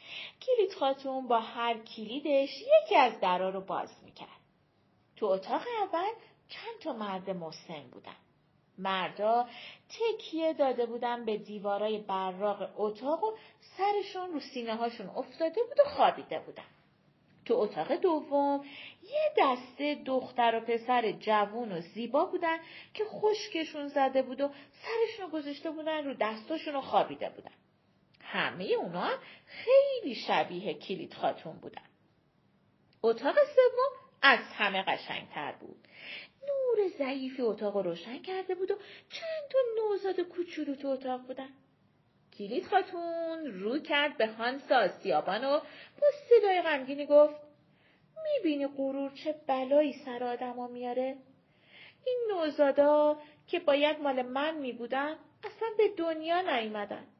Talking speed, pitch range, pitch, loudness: 125 wpm, 240-335 Hz, 285 Hz, -31 LUFS